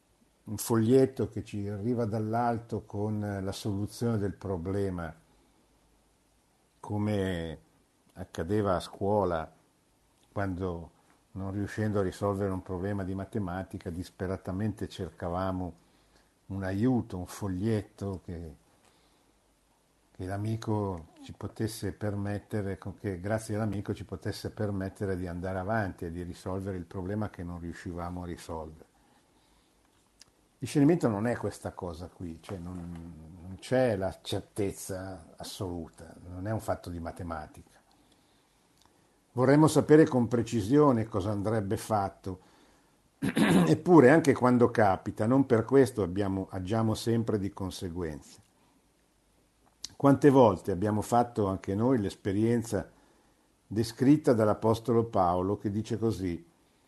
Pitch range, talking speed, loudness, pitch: 95-110 Hz, 115 wpm, -29 LUFS, 100 Hz